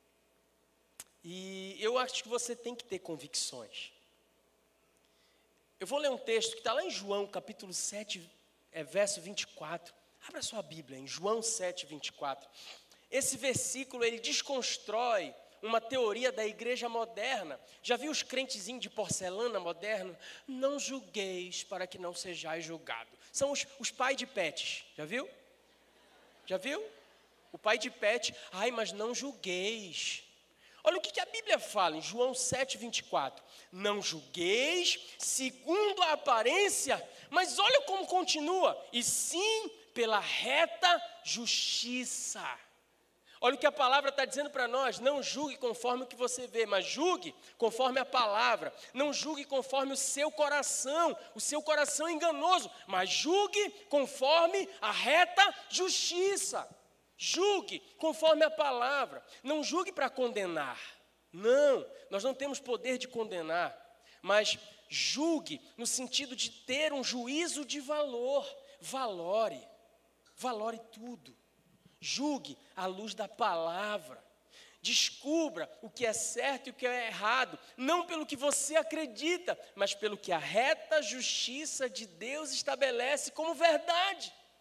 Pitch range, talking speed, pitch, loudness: 215-305 Hz, 135 wpm, 255 Hz, -33 LUFS